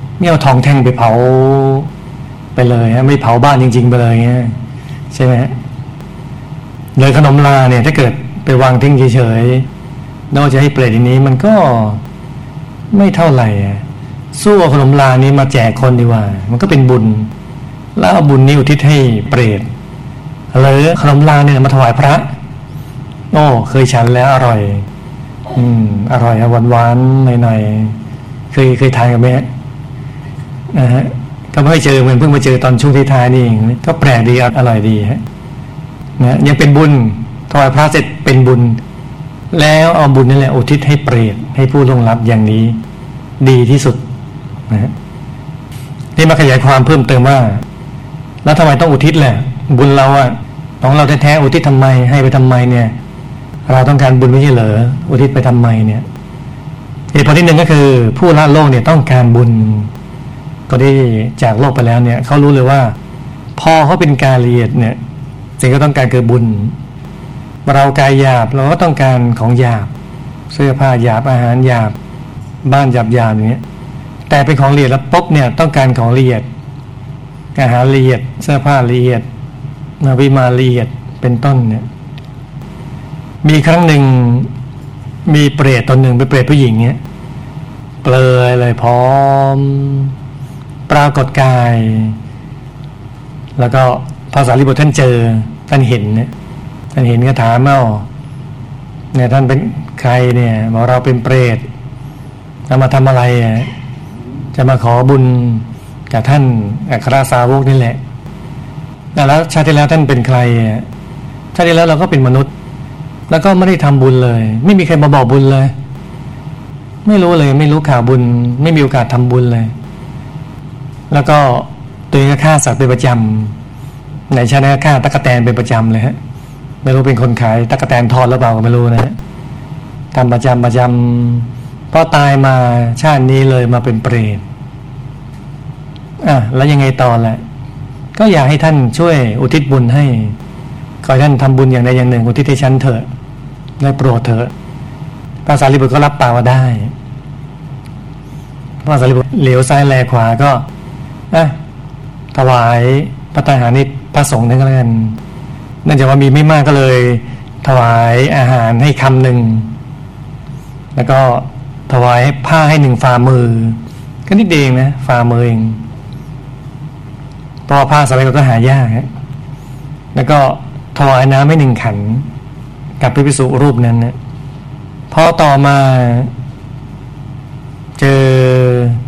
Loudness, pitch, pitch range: -9 LUFS, 135 Hz, 125-145 Hz